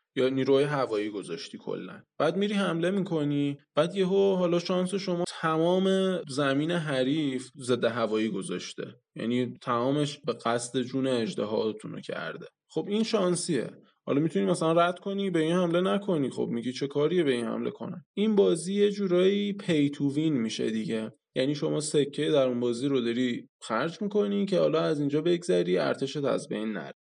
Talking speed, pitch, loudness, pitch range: 165 wpm, 150 Hz, -28 LUFS, 130-180 Hz